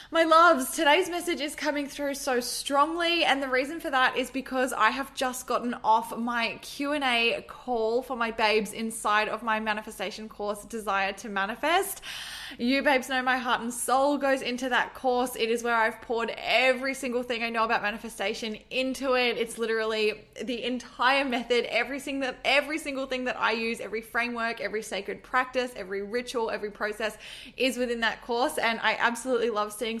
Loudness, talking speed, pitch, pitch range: -27 LUFS, 180 wpm, 240 Hz, 225-265 Hz